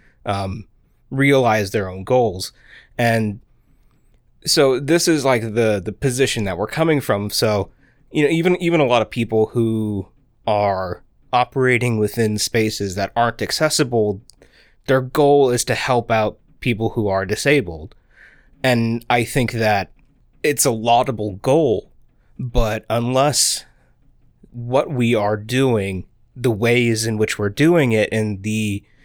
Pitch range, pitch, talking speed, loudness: 105-130 Hz, 115 Hz, 140 wpm, -19 LUFS